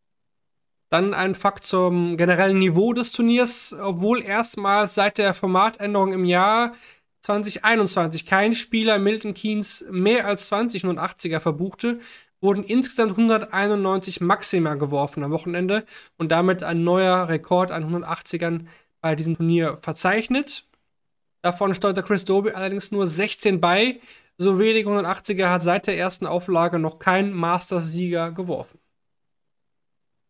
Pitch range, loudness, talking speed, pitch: 175-210 Hz, -21 LUFS, 125 wpm, 190 Hz